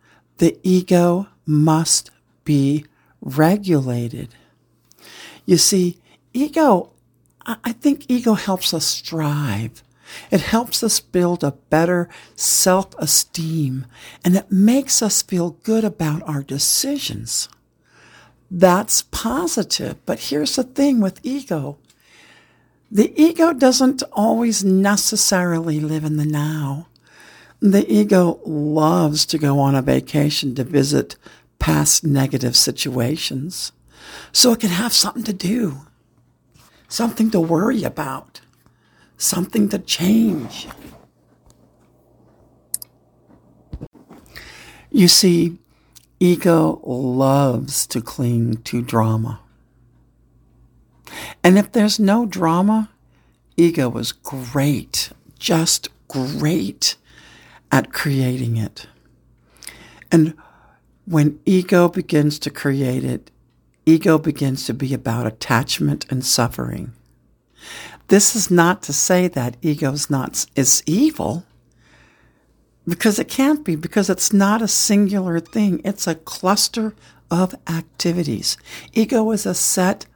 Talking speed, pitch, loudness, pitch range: 105 wpm, 170 Hz, -18 LUFS, 140-205 Hz